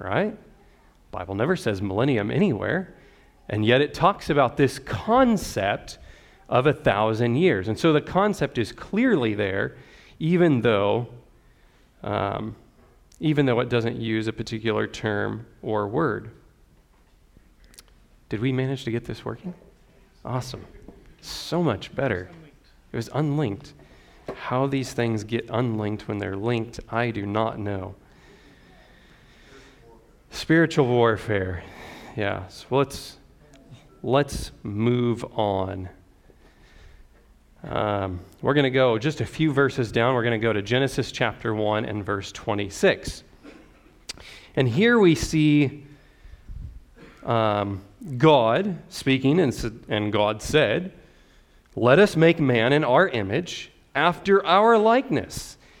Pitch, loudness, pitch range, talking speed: 115 Hz, -23 LUFS, 105-145 Hz, 120 wpm